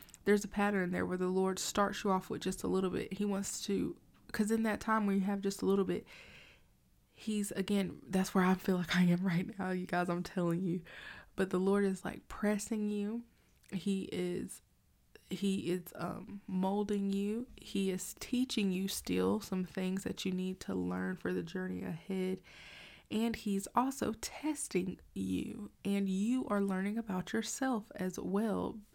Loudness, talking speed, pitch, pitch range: -36 LUFS, 180 wpm, 195 Hz, 185-205 Hz